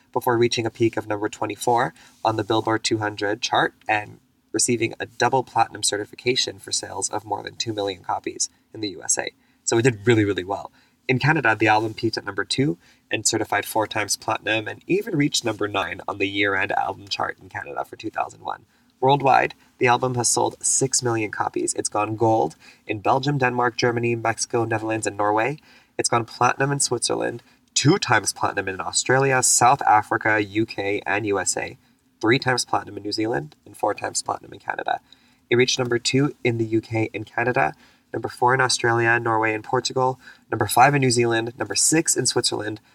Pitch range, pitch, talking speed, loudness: 110-125 Hz, 115 Hz, 185 wpm, -22 LUFS